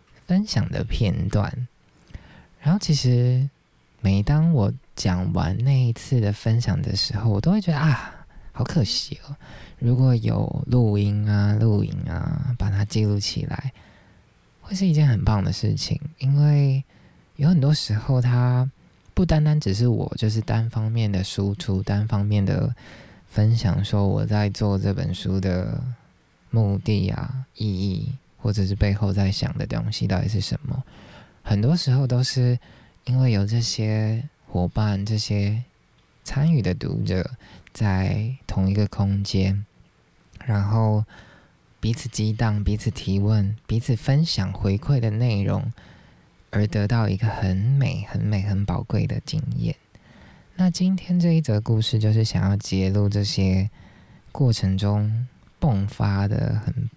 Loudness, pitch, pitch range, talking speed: -23 LUFS, 110 Hz, 100-130 Hz, 205 characters per minute